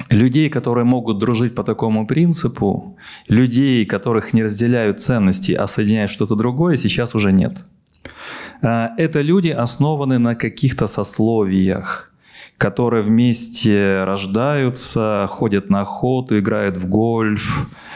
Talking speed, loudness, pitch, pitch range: 115 wpm, -17 LUFS, 115 Hz, 105-125 Hz